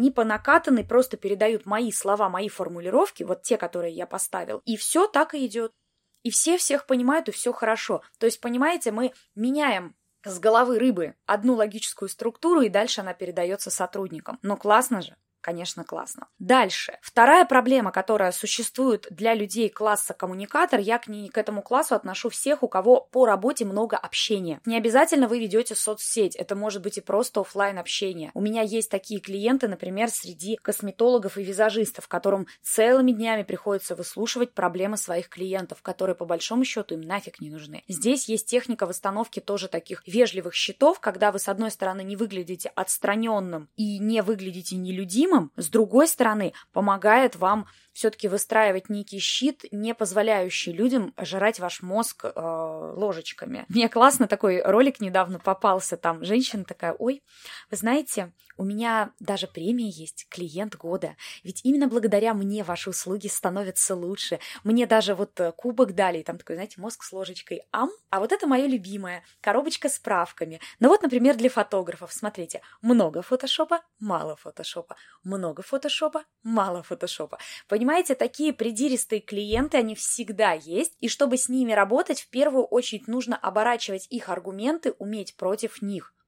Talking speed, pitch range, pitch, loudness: 160 wpm, 190-240 Hz, 215 Hz, -24 LUFS